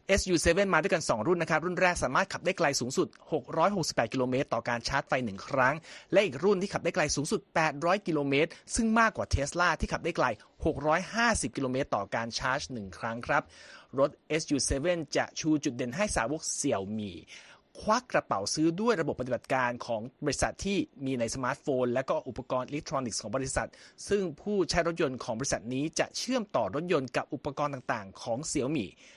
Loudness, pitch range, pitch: -30 LUFS, 135-180 Hz, 155 Hz